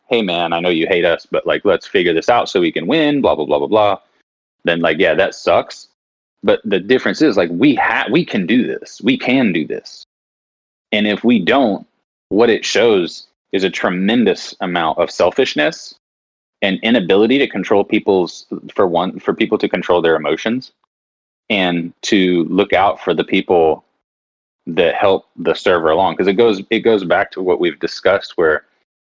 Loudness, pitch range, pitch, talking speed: -15 LUFS, 70-105 Hz, 90 Hz, 190 wpm